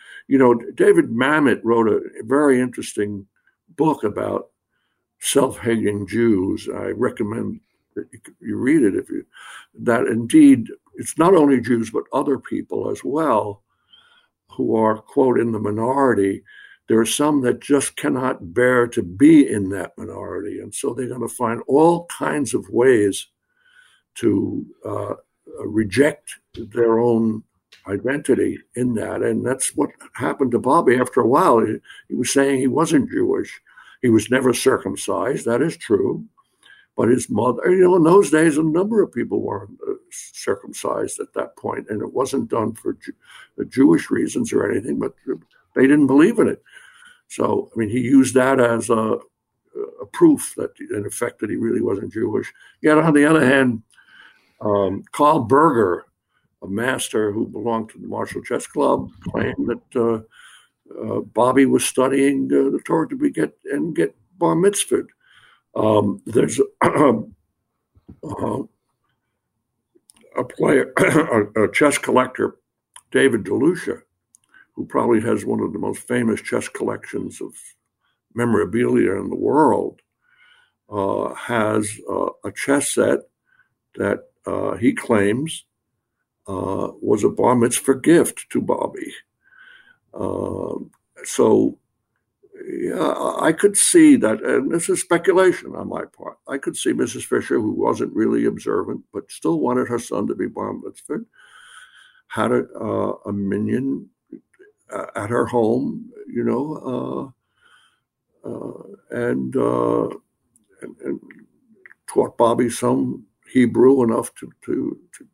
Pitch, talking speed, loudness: 170 Hz, 145 wpm, -19 LUFS